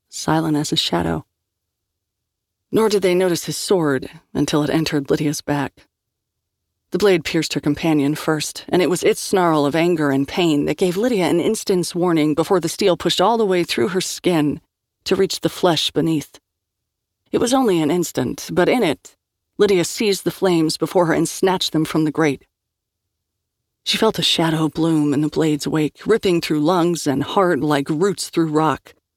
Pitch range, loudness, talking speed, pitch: 140-180 Hz, -19 LUFS, 185 wpm, 155 Hz